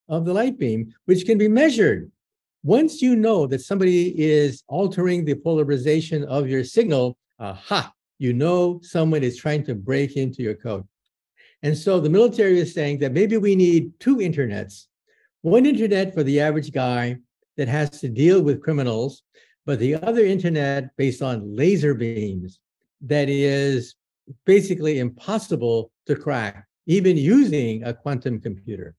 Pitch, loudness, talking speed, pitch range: 145 Hz, -21 LUFS, 155 wpm, 125-180 Hz